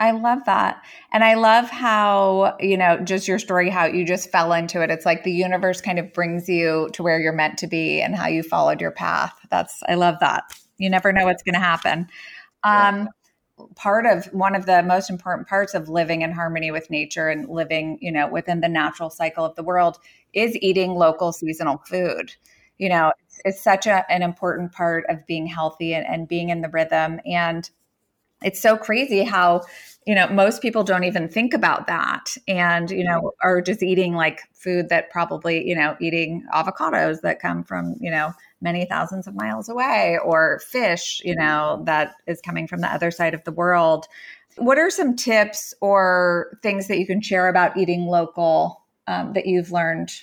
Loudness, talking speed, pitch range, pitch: -20 LUFS, 200 wpm, 165-195 Hz, 175 Hz